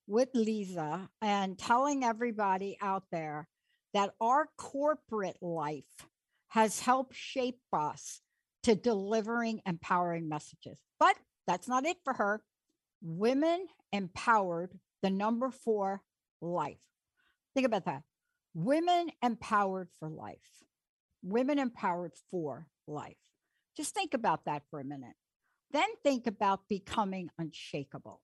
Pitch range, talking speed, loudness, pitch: 175-255 Hz, 115 wpm, -33 LUFS, 210 Hz